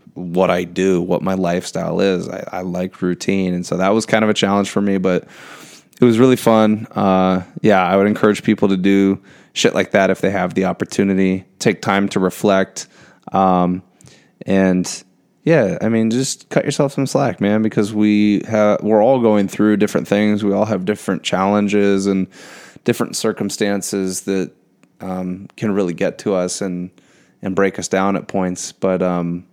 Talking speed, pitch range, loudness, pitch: 185 wpm, 90-105 Hz, -17 LUFS, 95 Hz